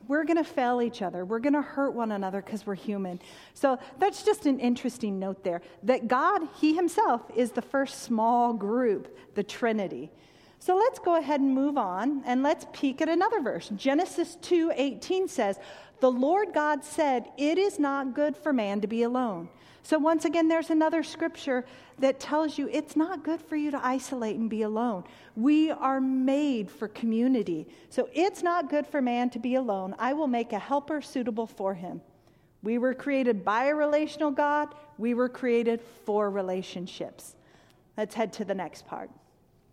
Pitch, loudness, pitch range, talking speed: 260 Hz, -28 LUFS, 225-300 Hz, 185 wpm